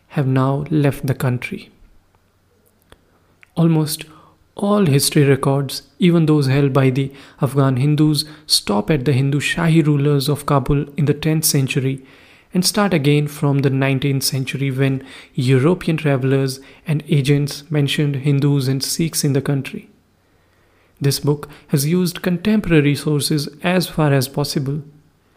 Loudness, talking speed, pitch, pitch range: -18 LUFS, 135 wpm, 145 Hz, 135-155 Hz